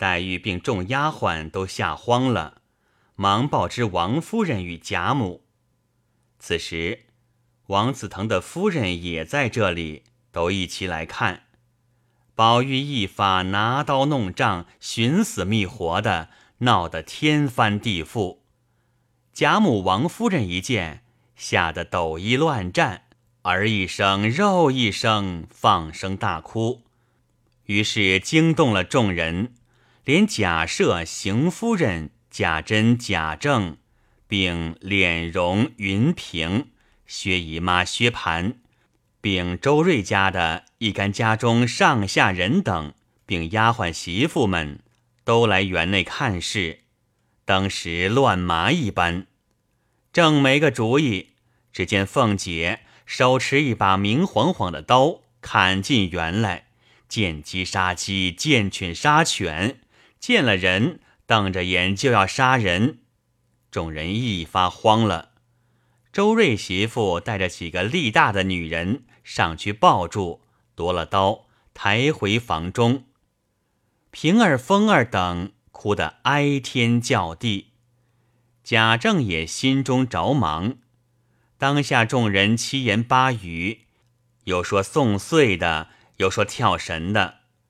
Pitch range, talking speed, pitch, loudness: 95-125 Hz, 165 characters per minute, 110 Hz, -21 LUFS